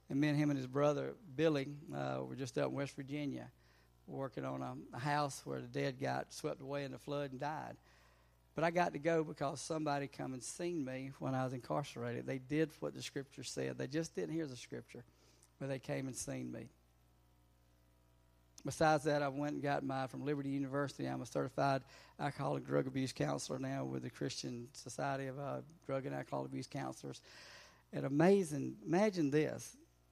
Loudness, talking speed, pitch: -40 LUFS, 195 wpm, 135 Hz